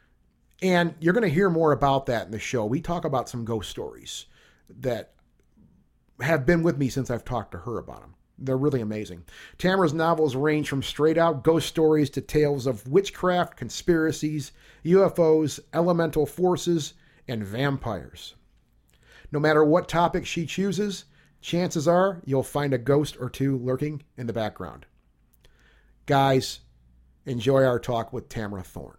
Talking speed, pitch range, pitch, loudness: 155 wpm, 120-165 Hz, 140 Hz, -25 LUFS